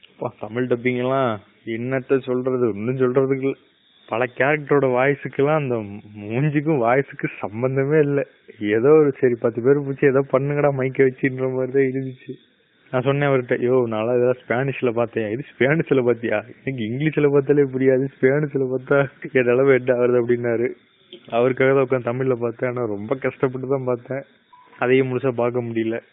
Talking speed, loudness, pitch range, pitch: 135 wpm, -20 LUFS, 120-140 Hz, 130 Hz